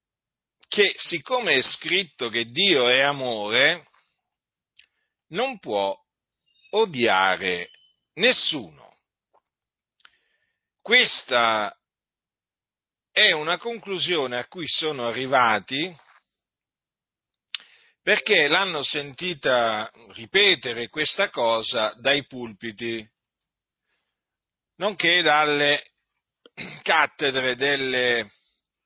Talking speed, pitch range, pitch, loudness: 65 wpm, 115-175 Hz, 140 Hz, -21 LUFS